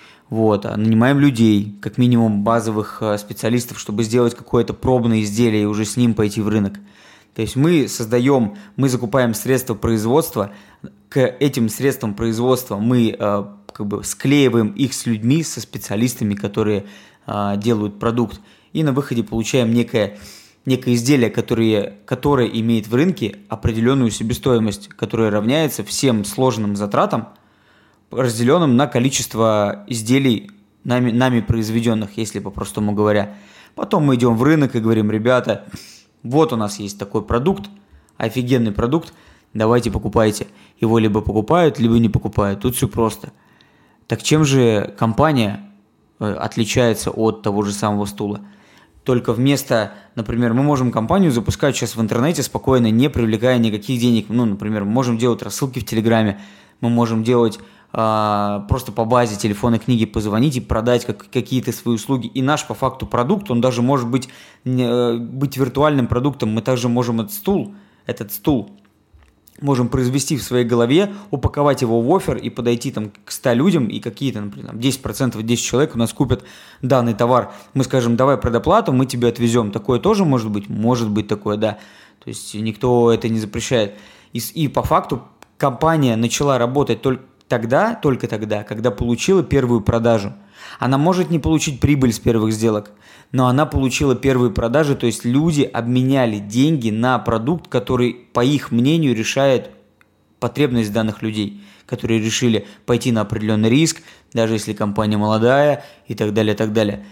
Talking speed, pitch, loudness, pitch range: 155 wpm, 120 Hz, -18 LUFS, 110-130 Hz